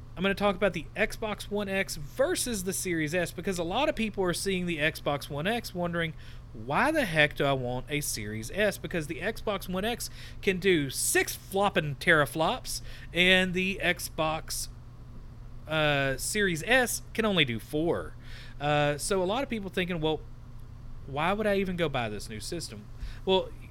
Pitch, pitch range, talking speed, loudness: 165 Hz, 125-195 Hz, 180 wpm, -29 LUFS